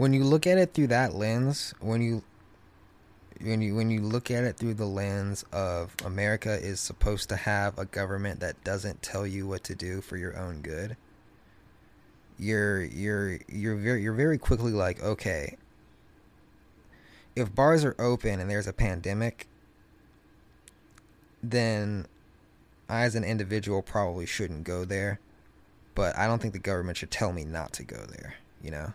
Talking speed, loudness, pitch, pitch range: 165 wpm, -30 LUFS, 100 Hz, 95-115 Hz